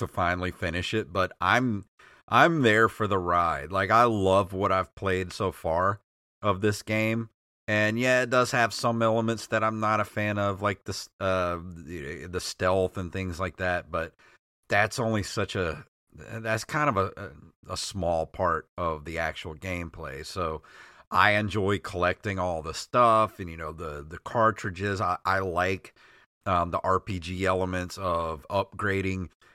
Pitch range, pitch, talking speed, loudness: 90-110 Hz, 95 Hz, 165 wpm, -27 LUFS